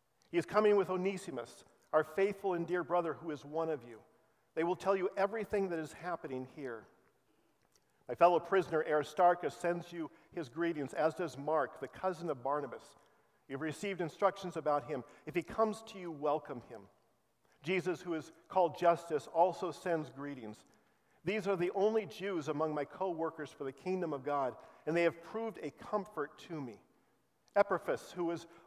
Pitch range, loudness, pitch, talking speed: 150-185 Hz, -36 LUFS, 170 Hz, 180 wpm